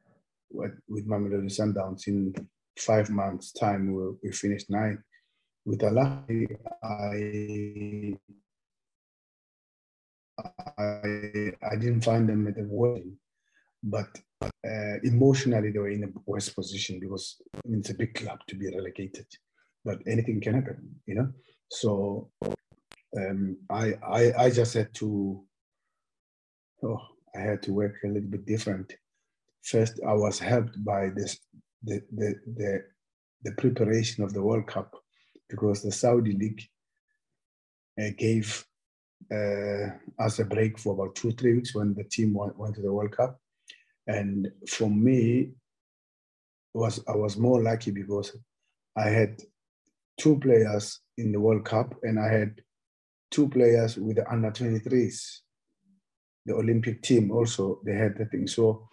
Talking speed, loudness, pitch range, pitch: 140 wpm, -28 LUFS, 100-115 Hz, 105 Hz